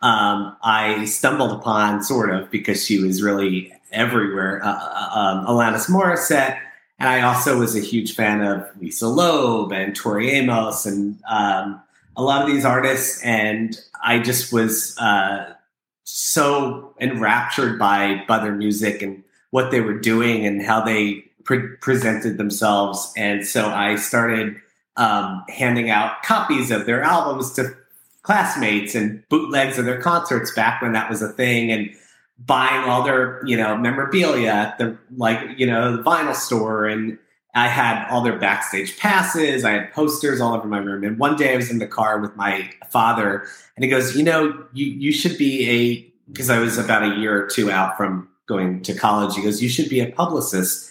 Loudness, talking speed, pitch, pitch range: -19 LUFS, 180 wpm, 110 Hz, 105-130 Hz